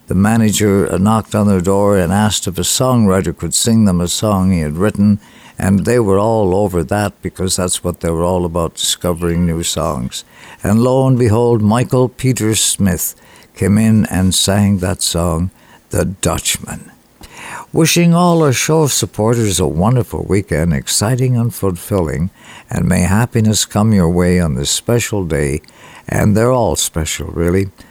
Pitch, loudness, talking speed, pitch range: 100 Hz, -14 LUFS, 165 wpm, 90-110 Hz